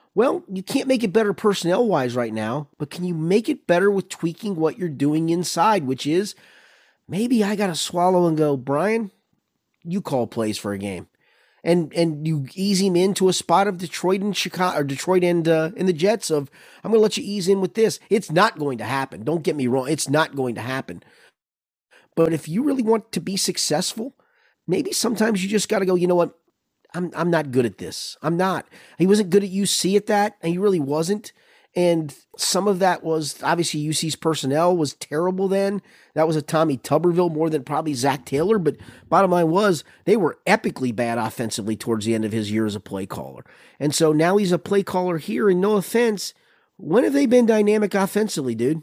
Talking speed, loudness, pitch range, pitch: 210 wpm, -21 LUFS, 150-200 Hz, 175 Hz